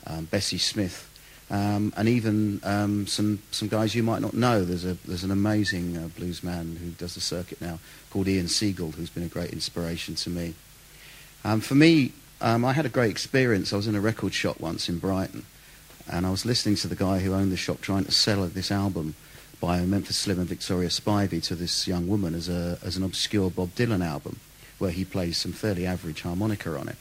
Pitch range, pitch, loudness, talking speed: 85-105 Hz, 95 Hz, -26 LUFS, 220 wpm